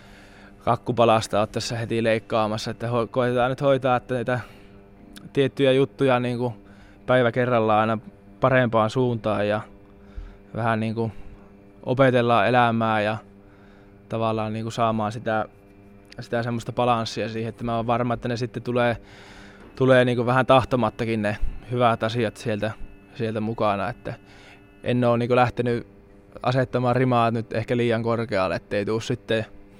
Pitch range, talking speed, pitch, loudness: 100-120 Hz, 130 wpm, 115 Hz, -23 LUFS